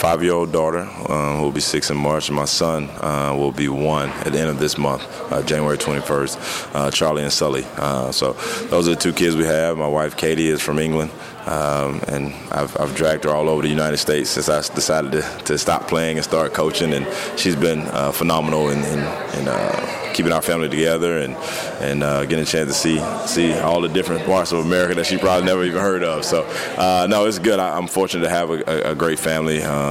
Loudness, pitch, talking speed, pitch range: -19 LUFS, 80 Hz, 235 wpm, 75-85 Hz